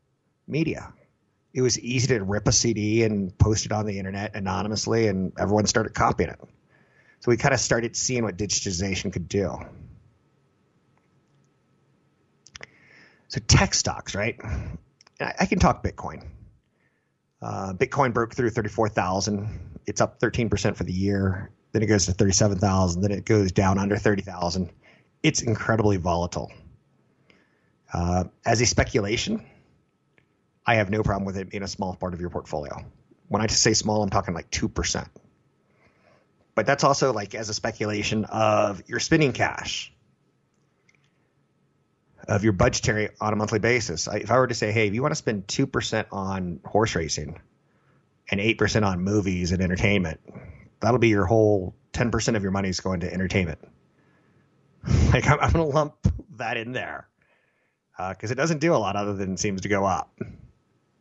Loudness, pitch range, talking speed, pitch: -24 LUFS, 95-115 Hz, 165 wpm, 105 Hz